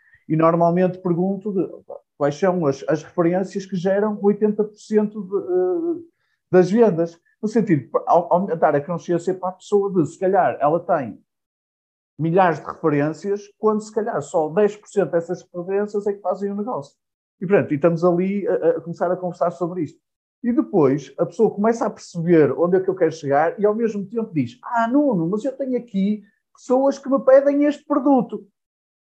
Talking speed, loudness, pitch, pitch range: 175 wpm, -20 LUFS, 195 Hz, 170-220 Hz